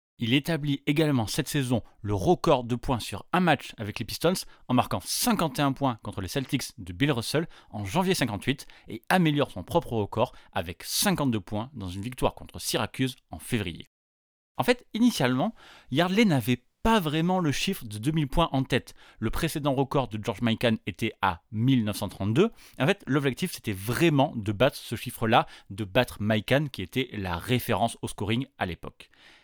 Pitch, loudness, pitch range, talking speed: 125 Hz, -27 LUFS, 105-150 Hz, 175 wpm